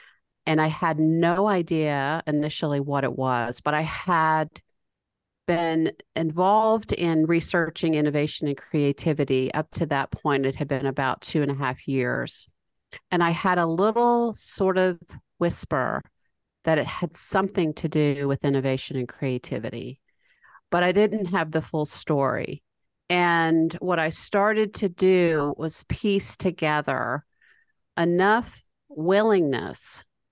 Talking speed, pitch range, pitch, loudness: 135 wpm, 140-180 Hz, 160 Hz, -24 LUFS